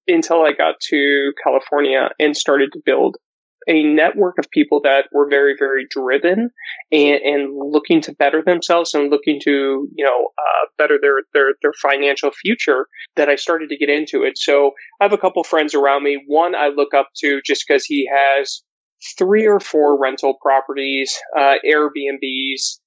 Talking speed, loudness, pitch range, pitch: 175 wpm, -16 LUFS, 140-165 Hz, 145 Hz